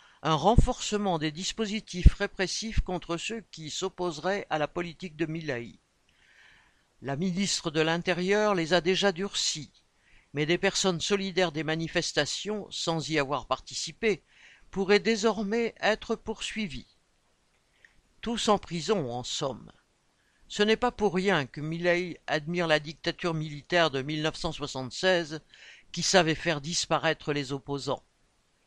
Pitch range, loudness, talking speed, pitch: 155-200 Hz, -29 LUFS, 125 wpm, 175 Hz